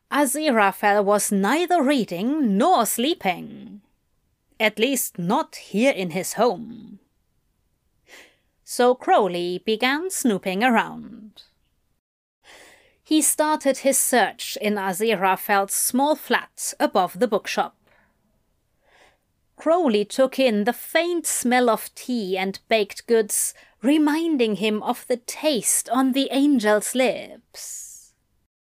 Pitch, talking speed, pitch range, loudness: 240 Hz, 105 wpm, 210-275 Hz, -21 LUFS